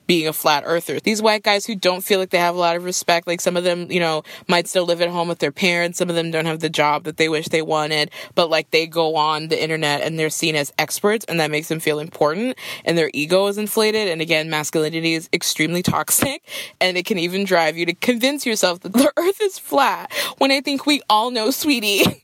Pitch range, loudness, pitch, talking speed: 160-210 Hz, -19 LUFS, 175 Hz, 250 wpm